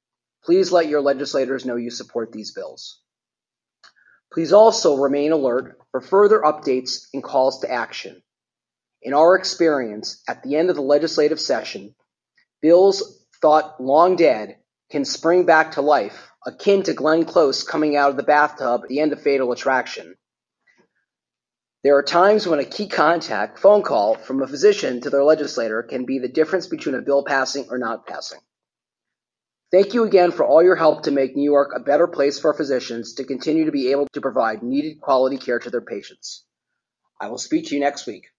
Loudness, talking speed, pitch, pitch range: -19 LUFS, 180 wpm, 150 Hz, 135-175 Hz